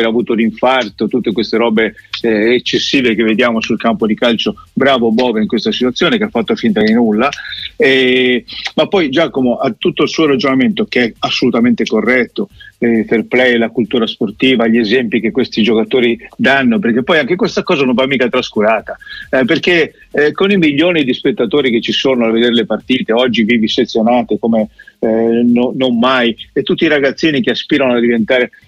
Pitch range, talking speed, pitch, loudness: 115-135 Hz, 190 wpm, 120 Hz, -12 LUFS